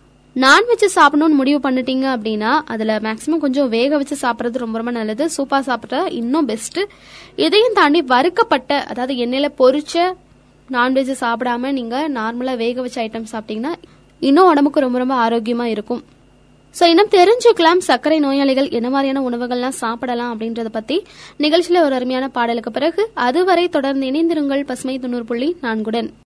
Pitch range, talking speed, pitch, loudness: 240-310 Hz, 140 wpm, 265 Hz, -16 LUFS